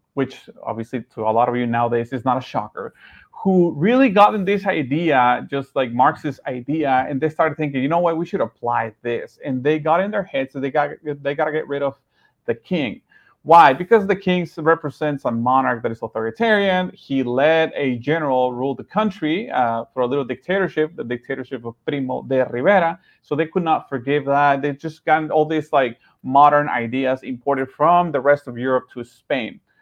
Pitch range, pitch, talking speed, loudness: 130-160 Hz, 140 Hz, 200 wpm, -19 LUFS